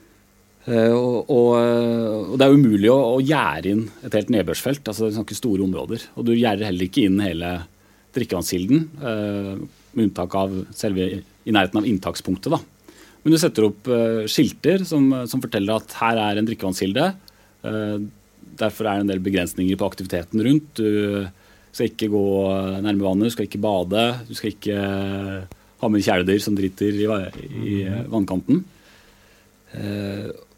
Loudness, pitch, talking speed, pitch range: -21 LUFS, 105 Hz, 160 wpm, 100-115 Hz